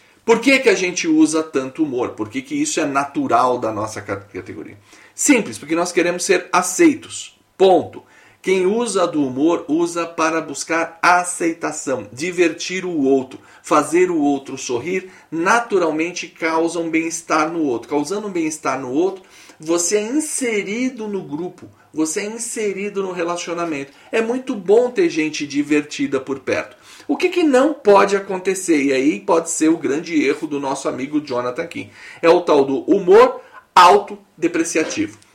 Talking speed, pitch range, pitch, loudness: 160 wpm, 155-245 Hz, 175 Hz, -18 LUFS